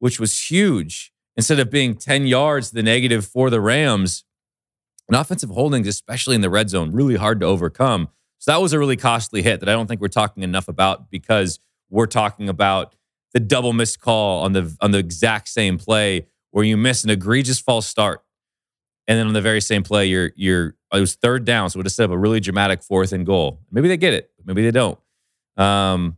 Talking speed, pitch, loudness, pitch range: 215 wpm, 110 Hz, -18 LUFS, 95-120 Hz